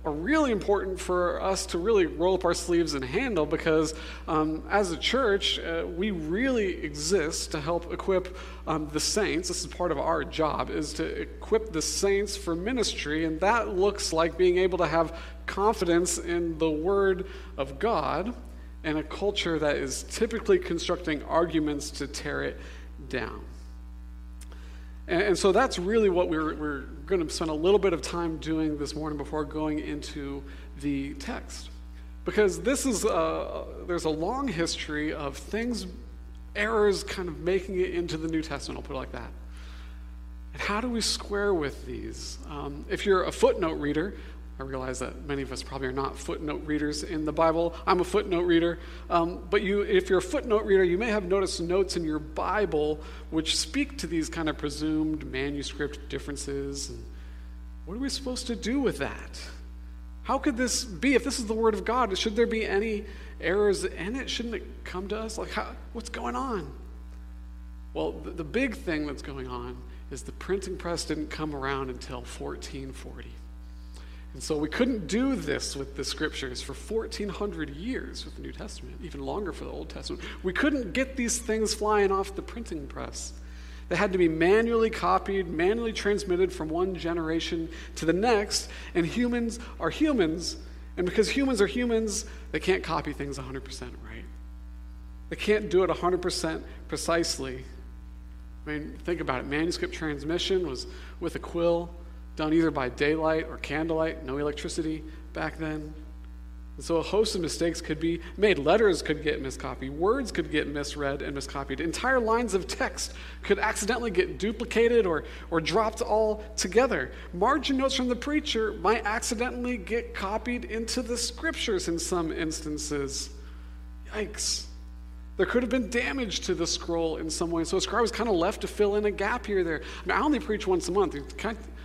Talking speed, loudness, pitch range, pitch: 180 wpm, -28 LUFS, 130-210 Hz, 165 Hz